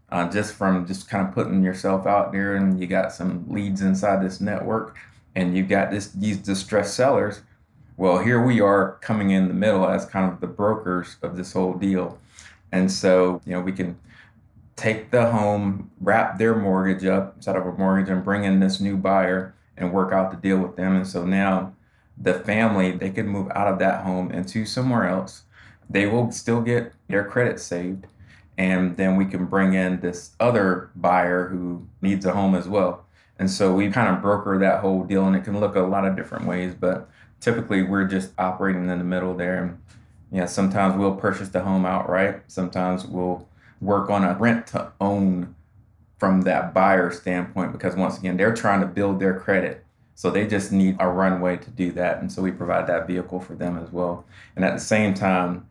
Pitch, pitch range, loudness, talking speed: 95 Hz, 90-100 Hz, -22 LUFS, 205 wpm